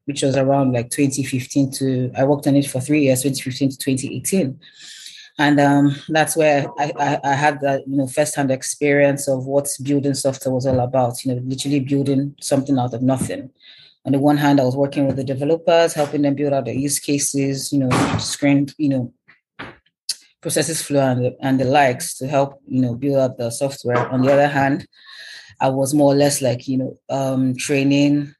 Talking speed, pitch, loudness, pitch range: 200 wpm, 140 Hz, -19 LUFS, 130-145 Hz